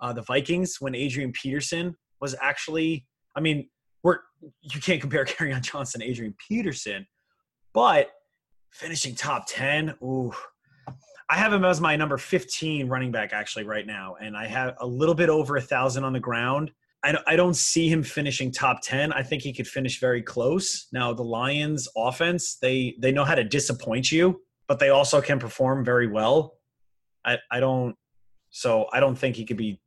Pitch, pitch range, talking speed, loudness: 135 Hz, 125-160 Hz, 180 wpm, -25 LUFS